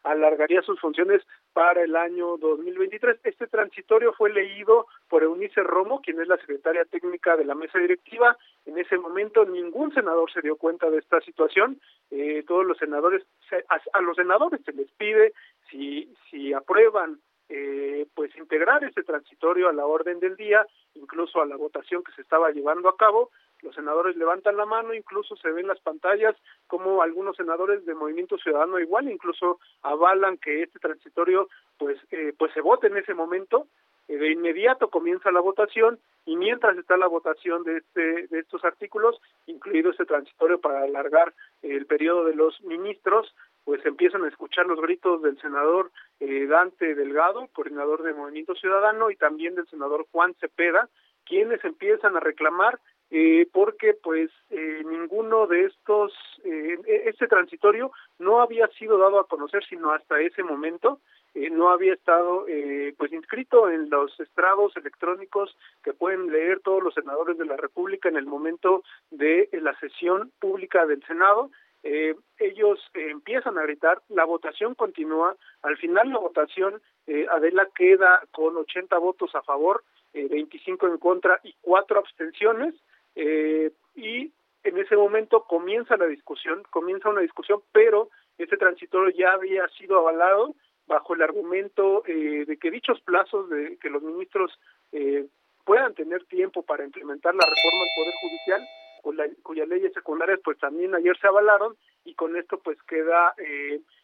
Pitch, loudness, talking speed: 185 Hz, -24 LUFS, 165 wpm